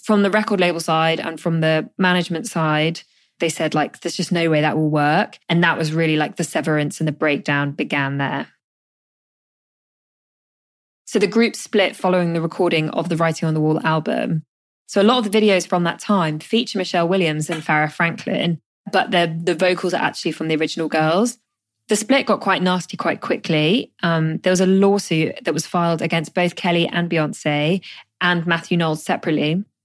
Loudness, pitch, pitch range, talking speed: -19 LUFS, 170 Hz, 155-190 Hz, 190 wpm